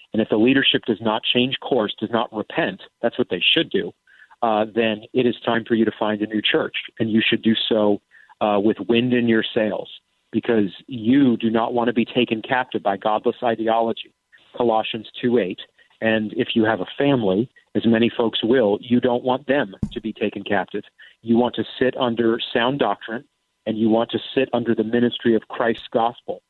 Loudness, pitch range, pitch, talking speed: -21 LUFS, 110-120 Hz, 115 Hz, 205 wpm